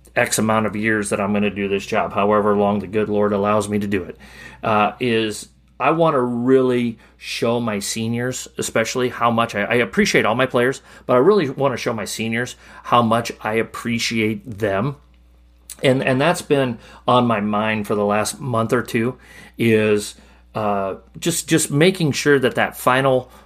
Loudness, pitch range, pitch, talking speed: -19 LUFS, 105-125 Hz, 115 Hz, 190 wpm